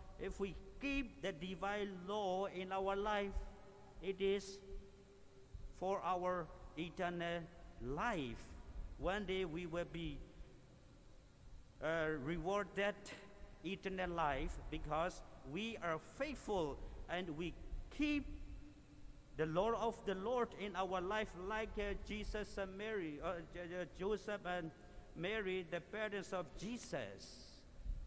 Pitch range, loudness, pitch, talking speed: 160-200 Hz, -43 LUFS, 185 Hz, 115 wpm